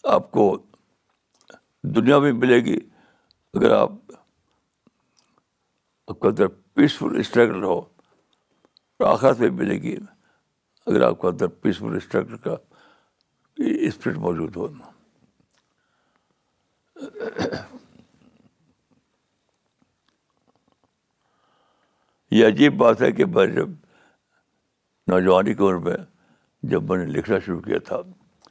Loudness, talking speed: -21 LUFS, 95 wpm